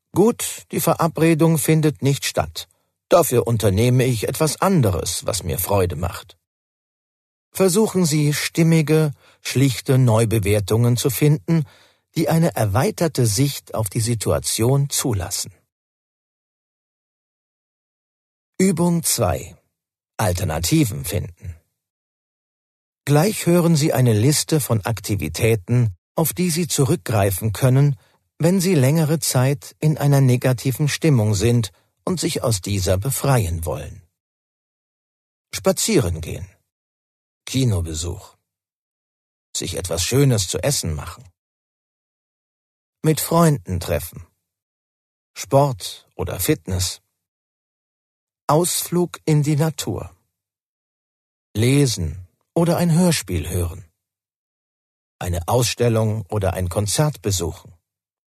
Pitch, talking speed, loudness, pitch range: 120 Hz, 95 wpm, -19 LUFS, 95-155 Hz